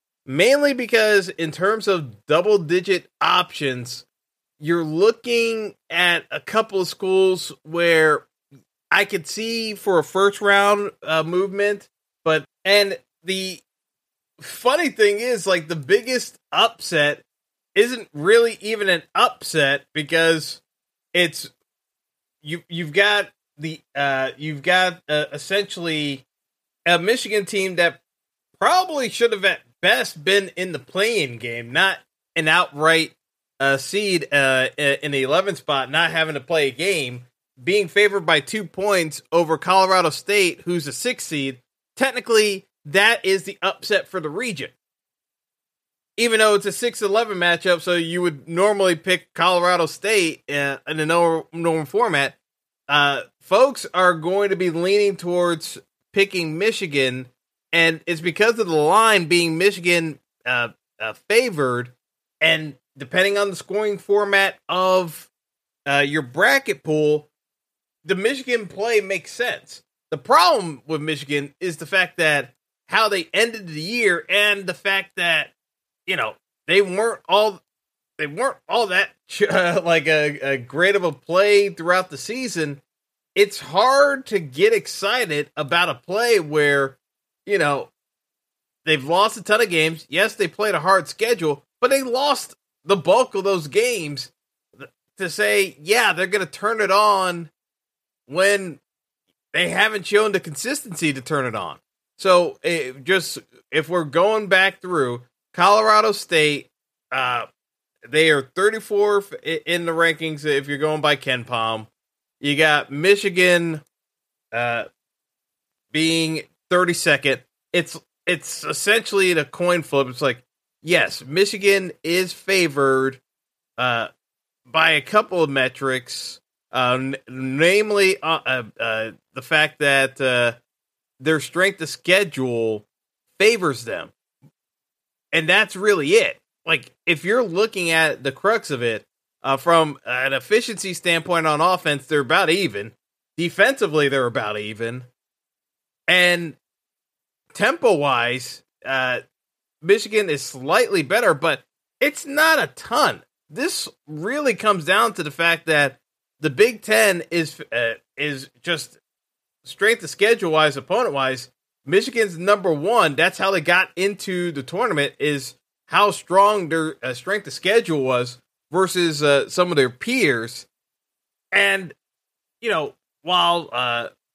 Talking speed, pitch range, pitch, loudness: 135 wpm, 145-200 Hz, 175 Hz, -19 LUFS